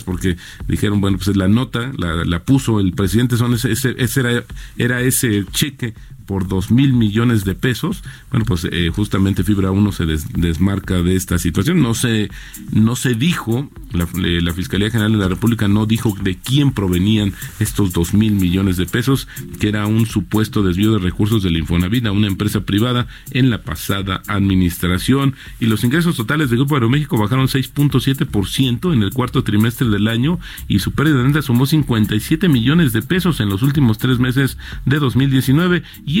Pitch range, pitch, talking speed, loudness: 100-130 Hz, 110 Hz, 190 wpm, -17 LUFS